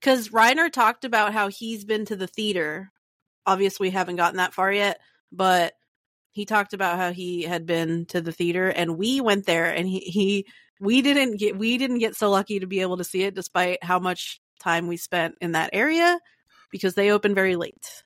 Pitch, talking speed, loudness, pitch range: 190 Hz, 210 wpm, -23 LUFS, 180-215 Hz